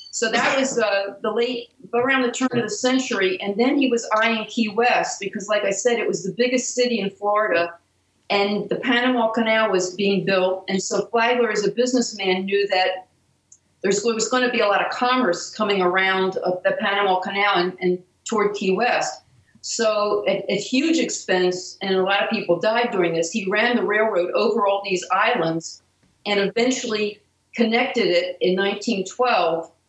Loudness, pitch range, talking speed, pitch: -21 LUFS, 190-235 Hz, 185 wpm, 205 Hz